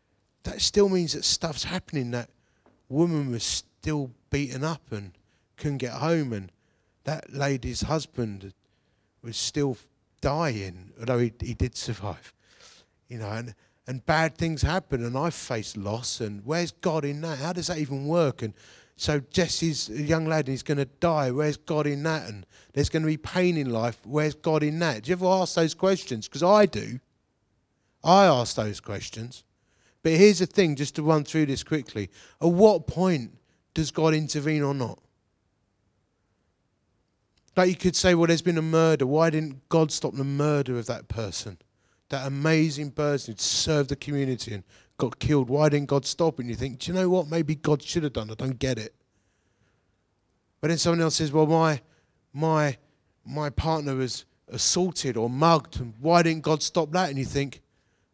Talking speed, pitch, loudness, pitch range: 185 wpm, 140 Hz, -26 LUFS, 115-160 Hz